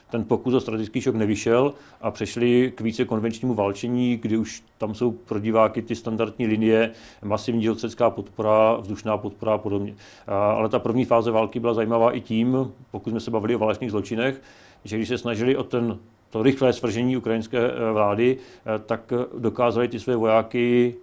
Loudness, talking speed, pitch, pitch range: -23 LUFS, 170 wpm, 115 Hz, 110-120 Hz